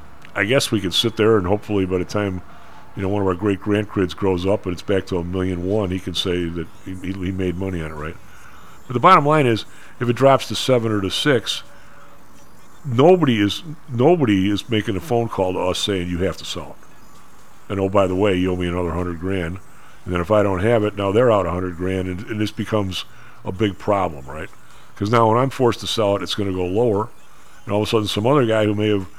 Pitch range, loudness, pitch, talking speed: 90-110 Hz, -20 LUFS, 100 Hz, 250 wpm